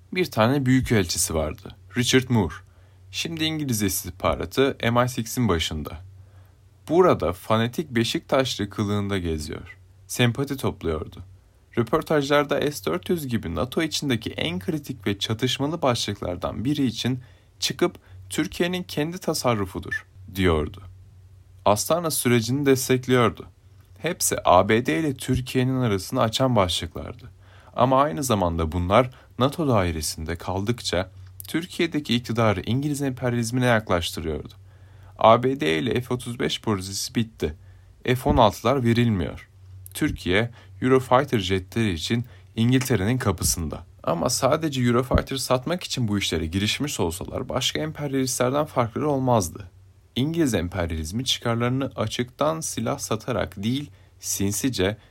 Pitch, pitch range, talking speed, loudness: 115 Hz, 95-130 Hz, 100 wpm, -24 LUFS